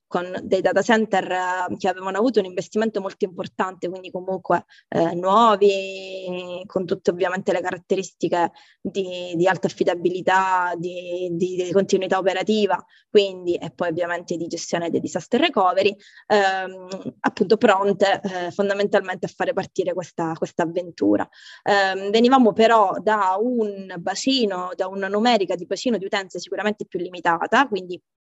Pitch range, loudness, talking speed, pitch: 180-200 Hz, -22 LUFS, 140 wpm, 190 Hz